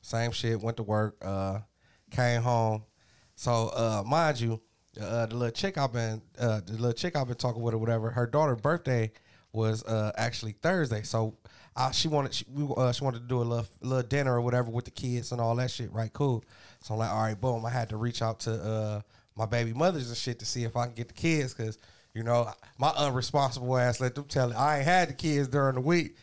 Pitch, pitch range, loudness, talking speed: 120 Hz, 110-130 Hz, -30 LUFS, 240 wpm